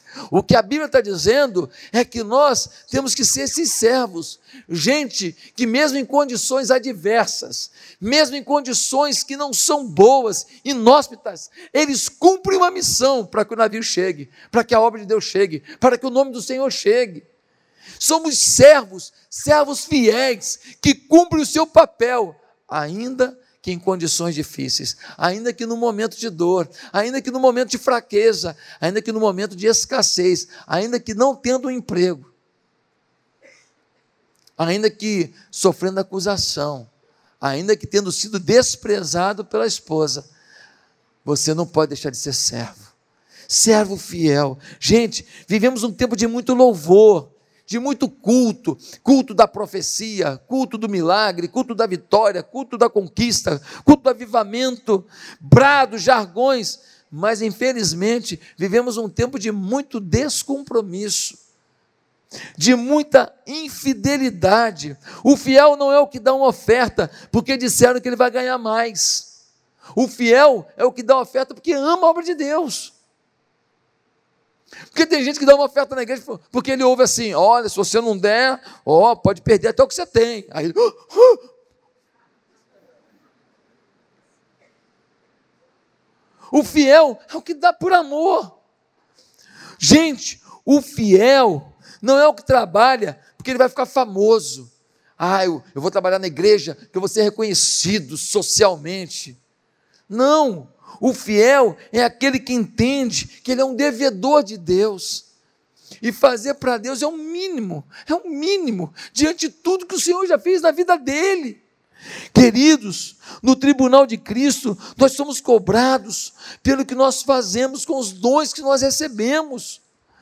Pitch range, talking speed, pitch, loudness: 200-275 Hz, 150 wpm, 240 Hz, -17 LUFS